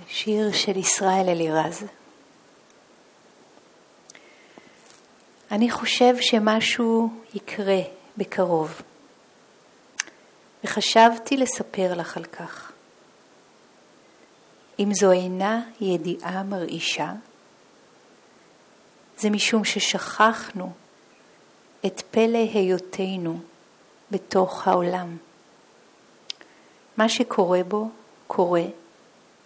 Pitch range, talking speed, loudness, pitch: 185-225 Hz, 65 wpm, -23 LUFS, 200 Hz